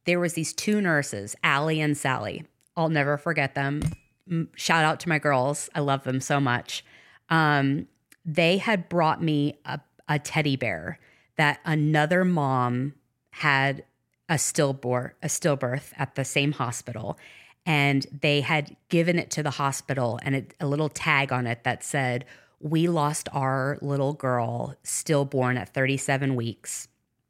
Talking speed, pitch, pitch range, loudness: 150 wpm, 145 Hz, 130-155 Hz, -25 LUFS